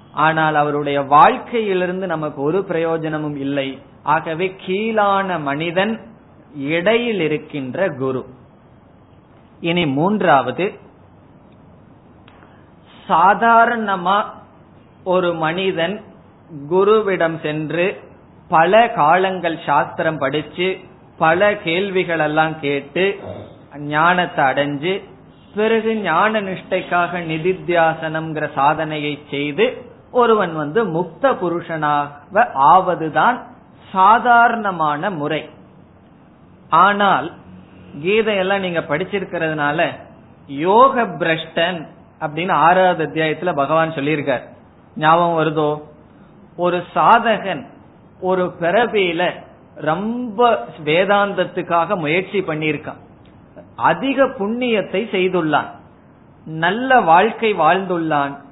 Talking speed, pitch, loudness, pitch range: 65 wpm, 170 Hz, -17 LUFS, 150-195 Hz